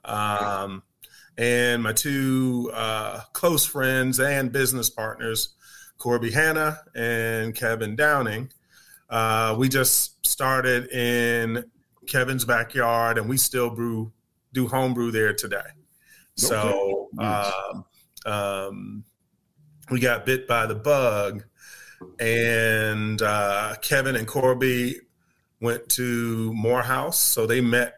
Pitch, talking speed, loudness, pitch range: 120 Hz, 110 wpm, -23 LUFS, 110-130 Hz